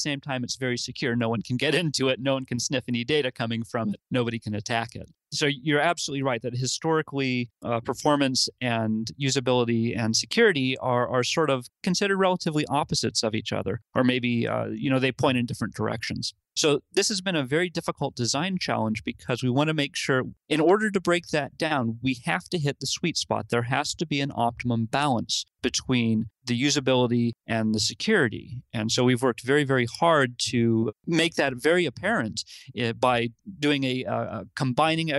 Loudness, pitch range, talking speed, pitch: -25 LUFS, 115-145 Hz, 195 wpm, 130 Hz